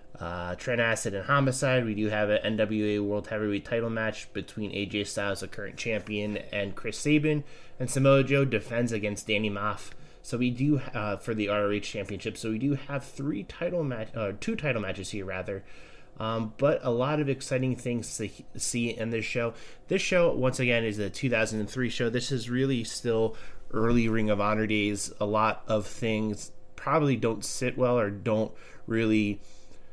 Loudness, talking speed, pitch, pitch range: -29 LUFS, 185 wpm, 110 Hz, 105-125 Hz